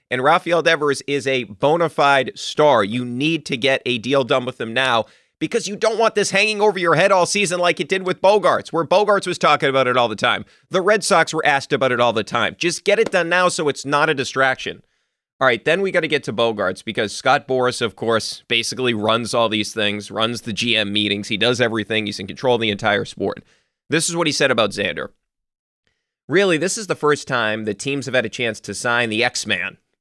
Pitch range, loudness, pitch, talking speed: 115-170 Hz, -18 LUFS, 135 Hz, 240 wpm